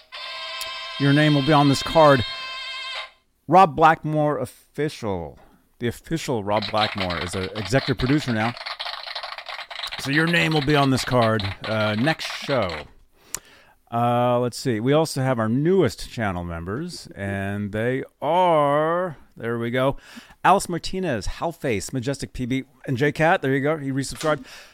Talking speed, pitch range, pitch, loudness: 145 wpm, 115-150 Hz, 135 Hz, -22 LUFS